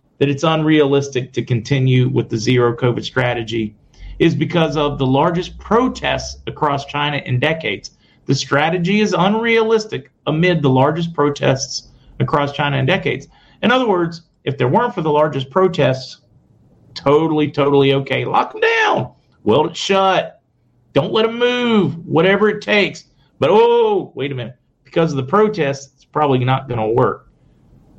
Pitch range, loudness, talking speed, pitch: 130-180 Hz, -16 LUFS, 155 wpm, 145 Hz